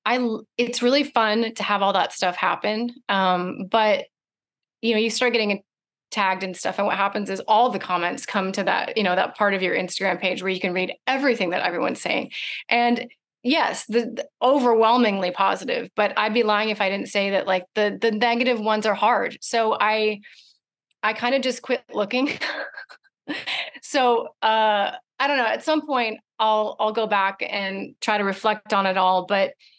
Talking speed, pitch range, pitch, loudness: 195 wpm, 195-245 Hz, 215 Hz, -22 LUFS